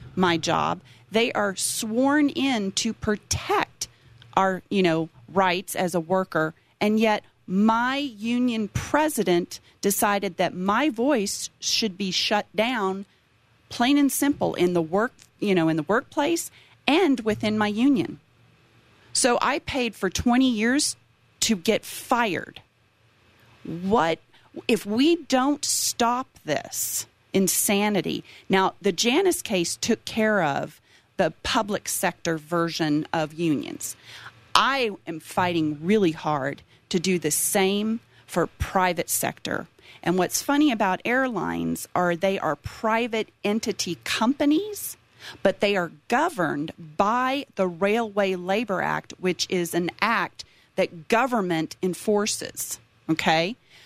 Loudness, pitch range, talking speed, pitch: -24 LUFS, 170-230 Hz, 125 wpm, 195 Hz